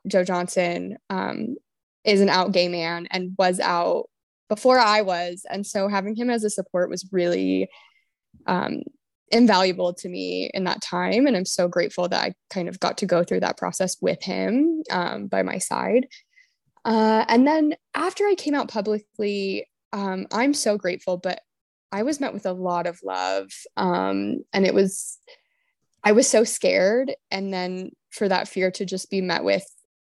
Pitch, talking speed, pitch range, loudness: 195 Hz, 180 wpm, 180-235 Hz, -23 LUFS